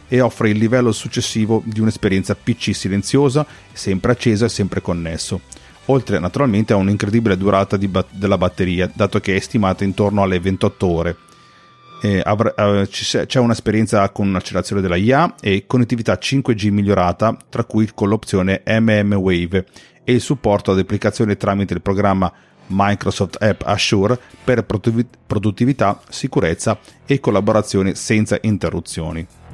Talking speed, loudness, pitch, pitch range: 140 wpm, -17 LUFS, 105 Hz, 95-115 Hz